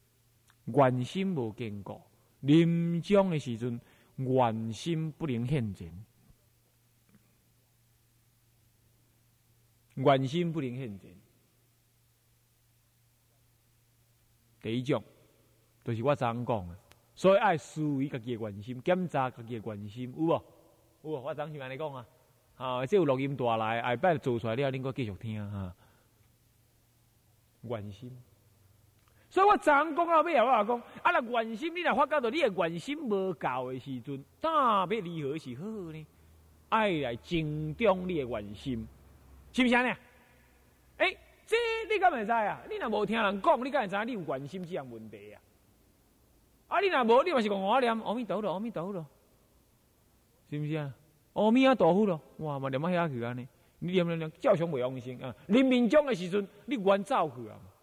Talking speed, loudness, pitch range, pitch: 225 characters per minute, -30 LUFS, 115-180 Hz, 125 Hz